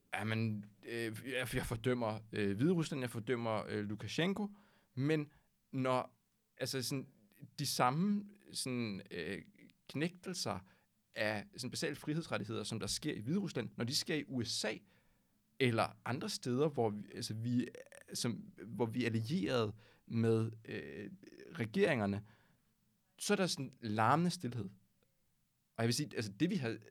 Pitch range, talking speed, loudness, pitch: 110-150 Hz, 135 wpm, -38 LUFS, 125 Hz